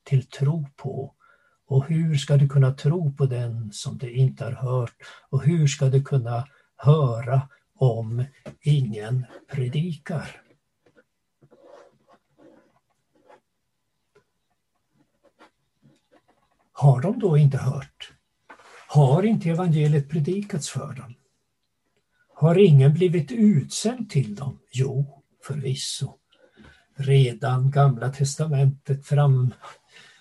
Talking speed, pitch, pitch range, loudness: 95 wpm, 140 Hz, 130-150 Hz, -23 LUFS